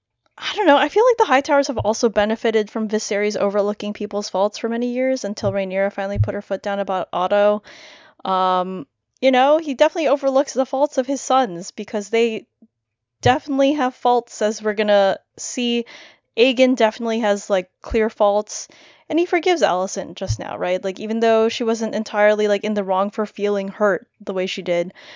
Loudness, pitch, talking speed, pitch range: -19 LUFS, 215 Hz, 190 wpm, 200-260 Hz